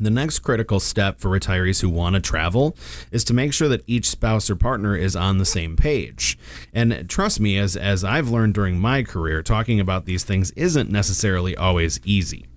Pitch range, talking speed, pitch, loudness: 90-115 Hz, 200 wpm, 100 Hz, -20 LUFS